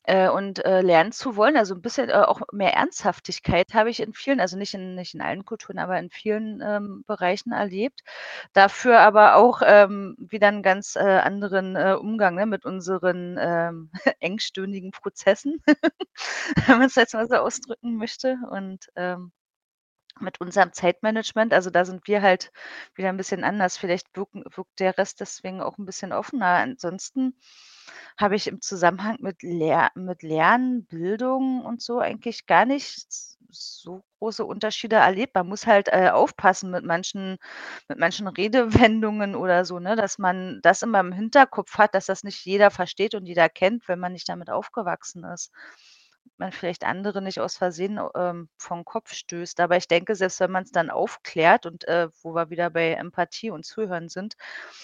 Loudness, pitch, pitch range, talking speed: -22 LUFS, 195 Hz, 180-220 Hz, 175 wpm